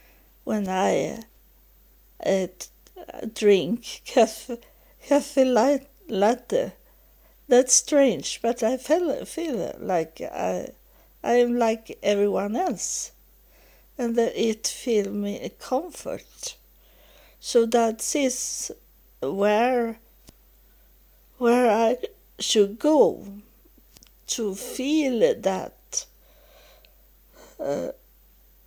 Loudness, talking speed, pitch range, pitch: -24 LUFS, 80 wpm, 220-270 Hz, 235 Hz